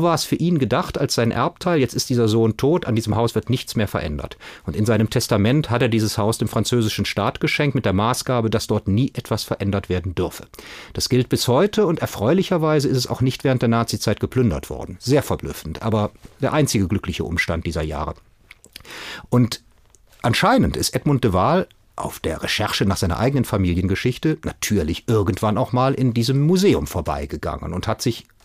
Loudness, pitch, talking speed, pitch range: -20 LUFS, 115 Hz, 190 wpm, 100-130 Hz